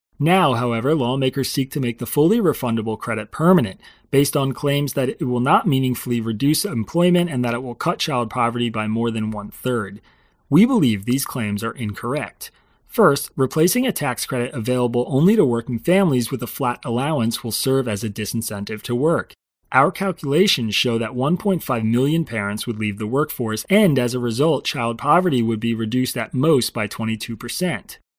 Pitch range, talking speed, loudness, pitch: 115-140 Hz, 180 wpm, -20 LUFS, 125 Hz